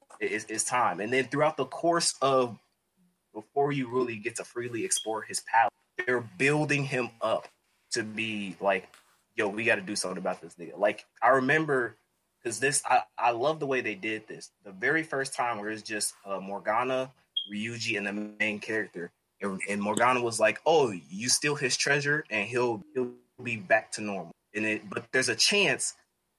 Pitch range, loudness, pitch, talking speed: 105-140 Hz, -28 LUFS, 120 Hz, 190 wpm